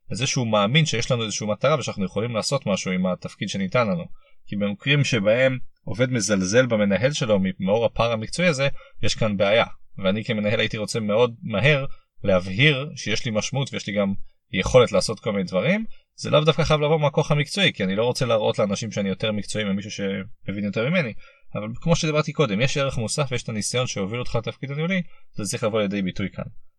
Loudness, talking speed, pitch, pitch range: -23 LUFS, 195 wpm, 120 Hz, 105-150 Hz